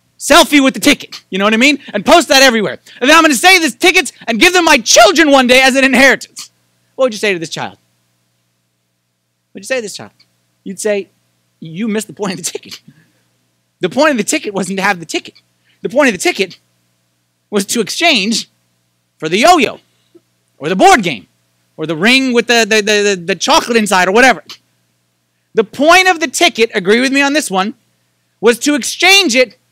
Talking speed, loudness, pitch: 215 wpm, -10 LUFS, 210 Hz